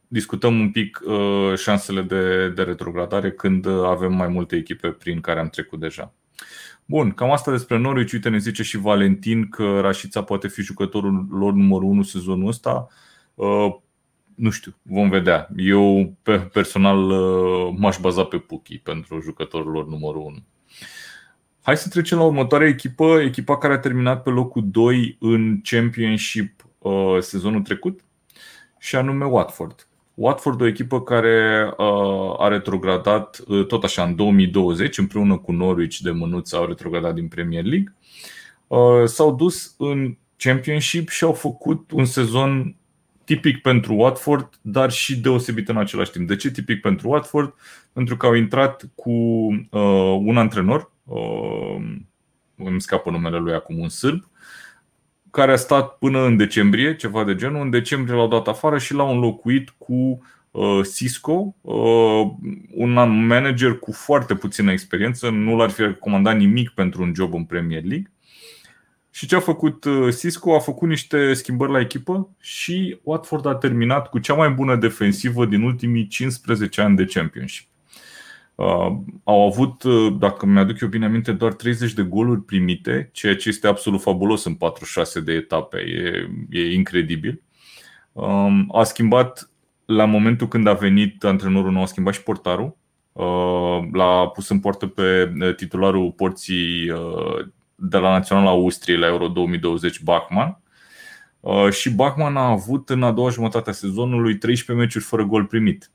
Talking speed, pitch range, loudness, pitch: 150 wpm, 95-130 Hz, -19 LUFS, 110 Hz